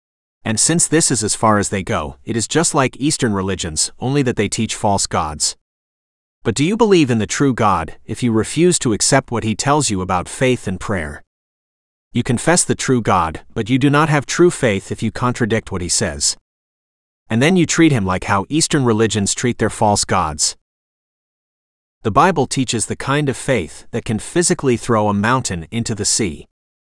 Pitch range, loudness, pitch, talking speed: 100-135 Hz, -17 LUFS, 115 Hz, 200 wpm